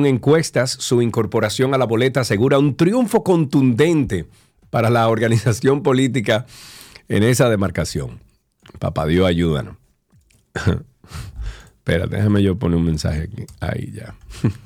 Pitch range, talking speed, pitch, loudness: 100-135 Hz, 125 wpm, 115 Hz, -18 LUFS